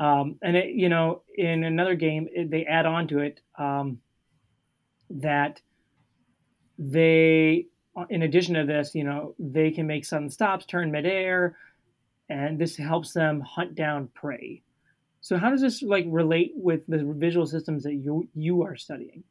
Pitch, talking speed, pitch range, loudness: 160 Hz, 160 wpm, 150-170 Hz, -25 LUFS